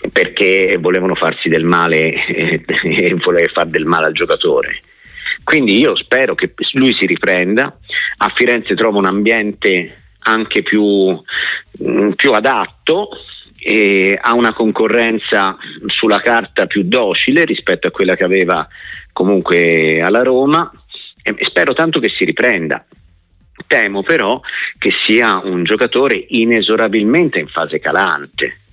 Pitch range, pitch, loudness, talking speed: 90-120 Hz, 110 Hz, -13 LUFS, 125 wpm